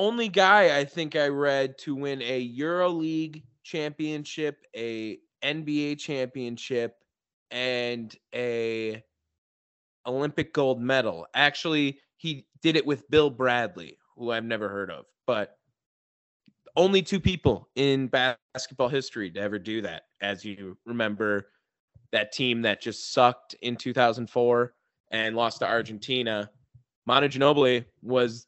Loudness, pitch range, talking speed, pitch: -26 LUFS, 115-145 Hz, 125 wpm, 125 Hz